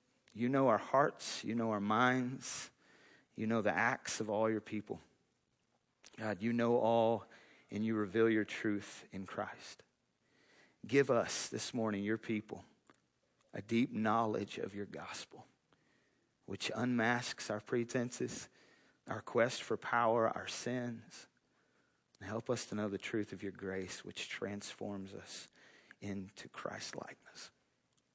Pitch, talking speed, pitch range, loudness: 110 Hz, 140 wpm, 100-120 Hz, -37 LUFS